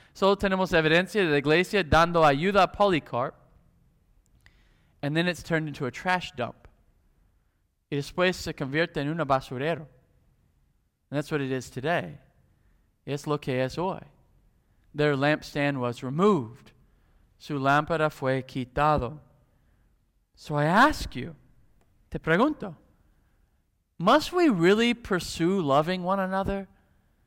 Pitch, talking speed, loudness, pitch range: 150 Hz, 125 wpm, -26 LUFS, 130-180 Hz